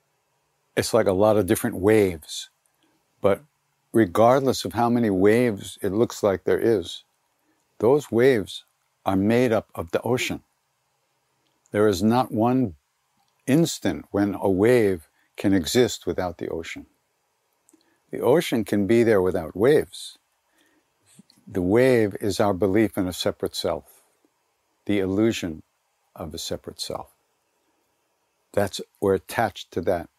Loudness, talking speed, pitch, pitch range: -23 LUFS, 130 wpm, 110 Hz, 100-120 Hz